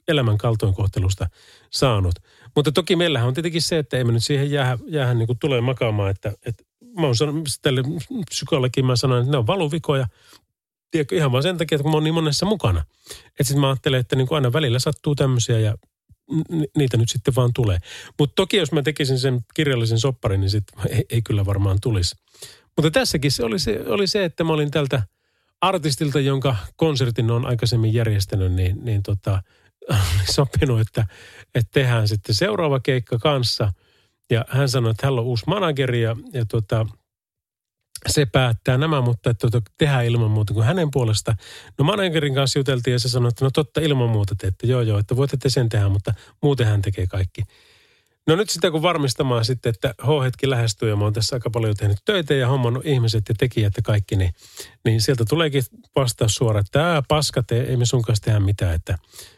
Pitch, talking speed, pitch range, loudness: 125 Hz, 190 wpm, 110-145 Hz, -21 LUFS